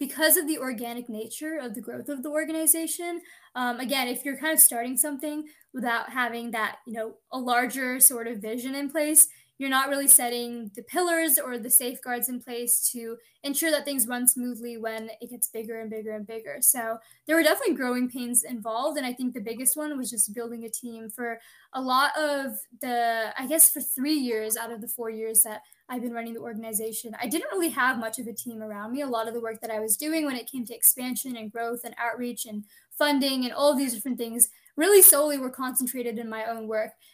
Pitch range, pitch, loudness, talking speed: 230-280 Hz, 245 Hz, -24 LUFS, 225 wpm